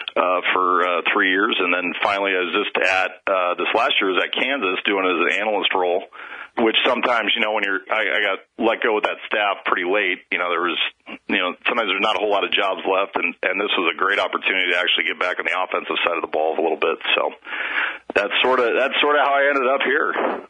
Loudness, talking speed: -19 LUFS, 260 wpm